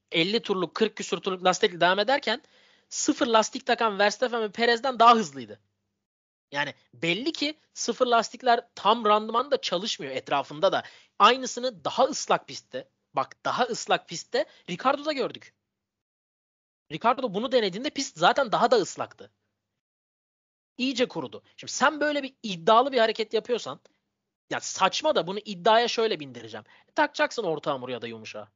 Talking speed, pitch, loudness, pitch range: 145 wpm, 225 Hz, -25 LUFS, 185-255 Hz